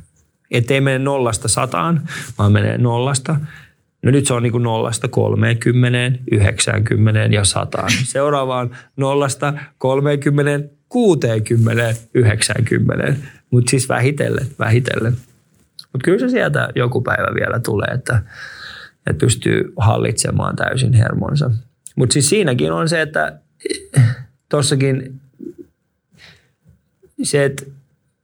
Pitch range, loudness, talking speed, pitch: 120-145 Hz, -17 LUFS, 105 wpm, 130 Hz